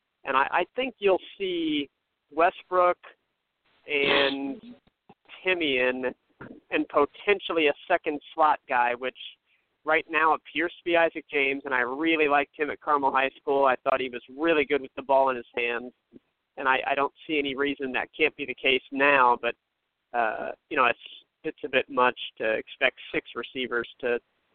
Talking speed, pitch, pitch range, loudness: 175 wpm, 140 Hz, 130-160 Hz, -26 LUFS